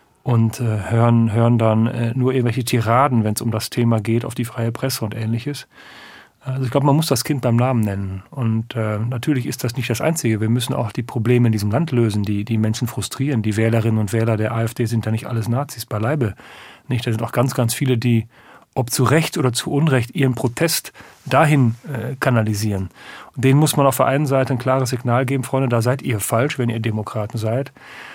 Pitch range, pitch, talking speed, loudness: 115-130 Hz, 120 Hz, 220 wpm, -19 LUFS